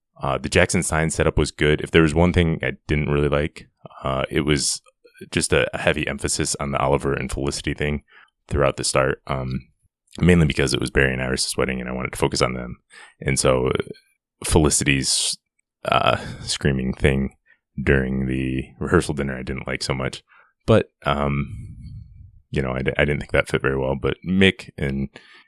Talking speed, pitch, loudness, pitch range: 185 wpm, 70 Hz, -21 LUFS, 65-75 Hz